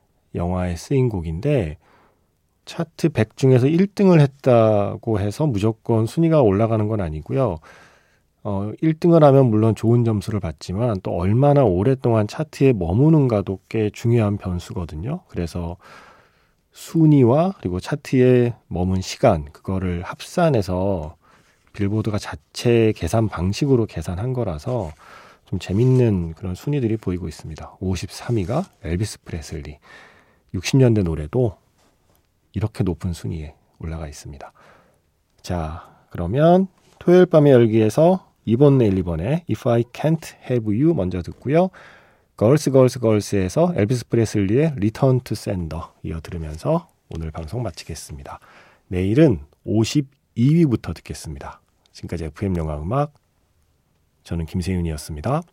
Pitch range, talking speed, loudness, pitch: 90-130 Hz, 315 characters per minute, -20 LUFS, 105 Hz